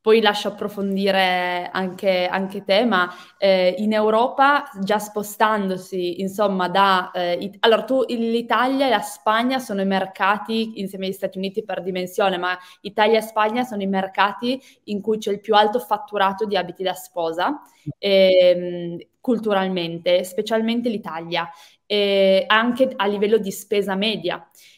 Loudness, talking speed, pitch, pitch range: -21 LUFS, 145 wpm, 200 Hz, 185-215 Hz